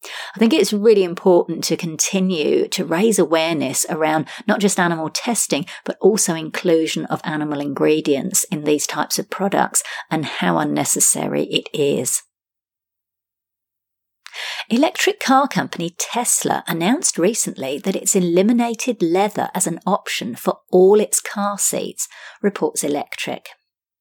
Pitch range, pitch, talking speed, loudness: 155-215 Hz, 180 Hz, 125 wpm, -18 LUFS